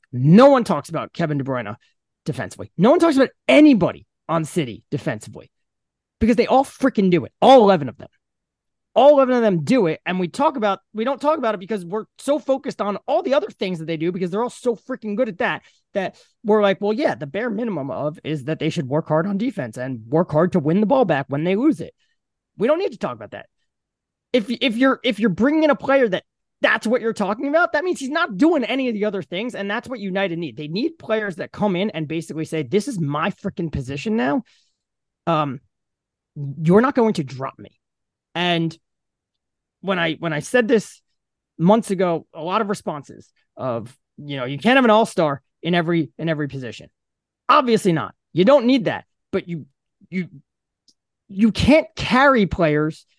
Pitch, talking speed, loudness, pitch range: 200 Hz, 215 wpm, -20 LUFS, 160-245 Hz